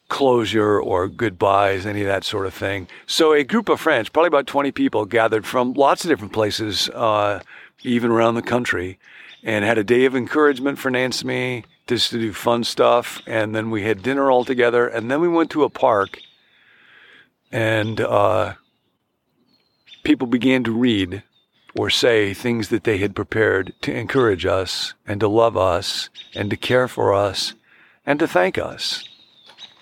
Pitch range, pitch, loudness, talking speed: 105-130 Hz, 115 Hz, -19 LUFS, 175 wpm